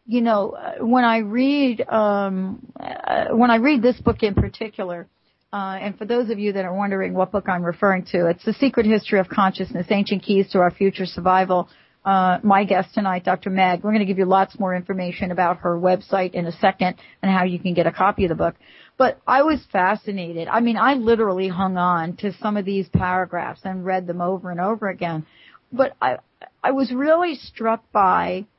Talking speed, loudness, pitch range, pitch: 210 wpm, -20 LUFS, 185-225 Hz, 195 Hz